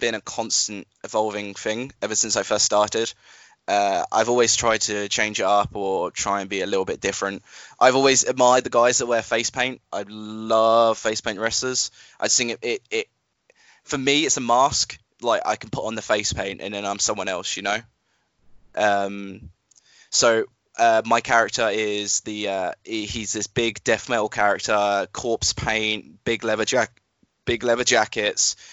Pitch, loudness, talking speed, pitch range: 110 Hz, -22 LUFS, 180 wpm, 100-120 Hz